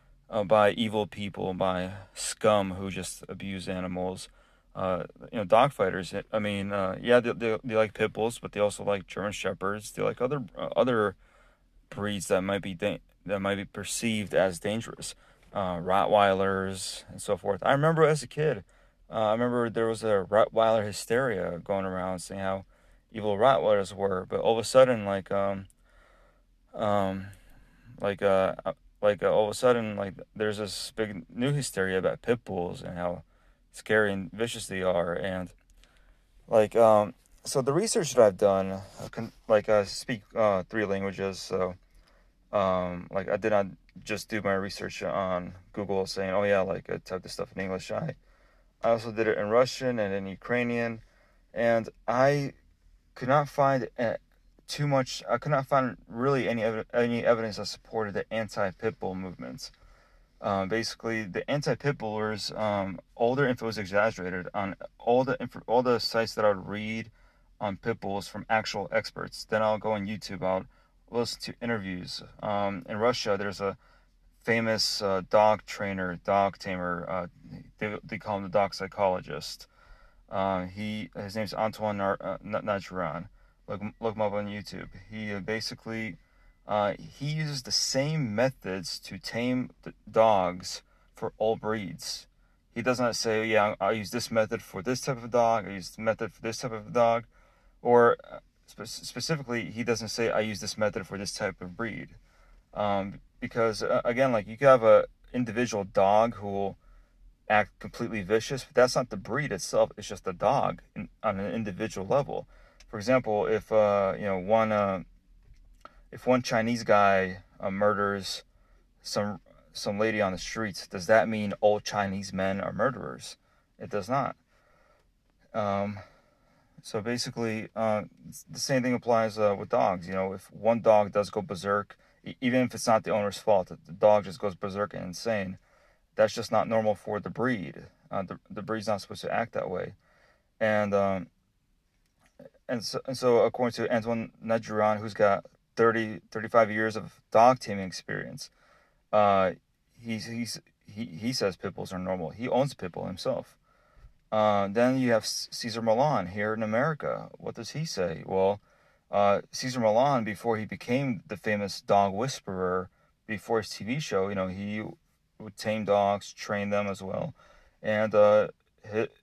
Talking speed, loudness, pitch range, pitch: 170 wpm, -28 LUFS, 95-115 Hz, 105 Hz